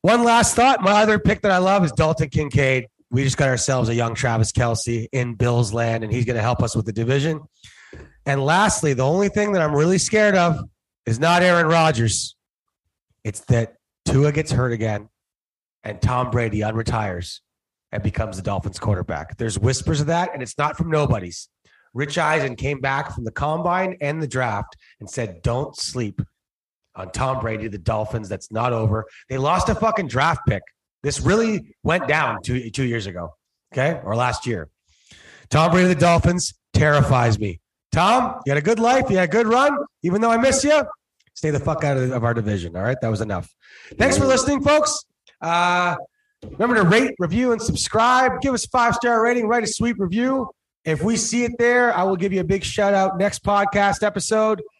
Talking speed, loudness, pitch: 200 wpm, -20 LUFS, 150 Hz